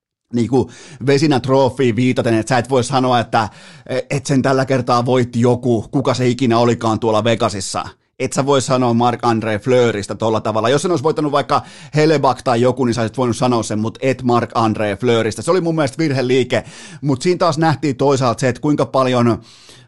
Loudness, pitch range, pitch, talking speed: -16 LUFS, 115-140 Hz, 125 Hz, 195 wpm